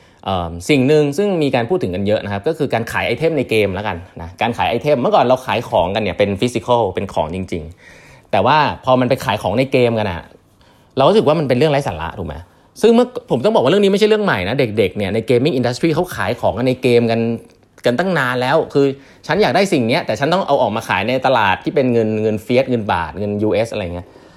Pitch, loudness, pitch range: 120 Hz, -16 LUFS, 100-145 Hz